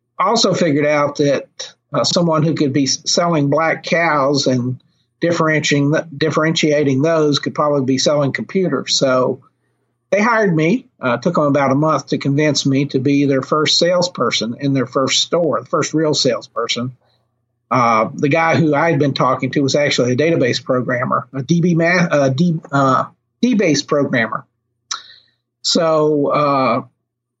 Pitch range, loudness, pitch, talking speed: 135-160 Hz, -16 LUFS, 145 Hz, 155 wpm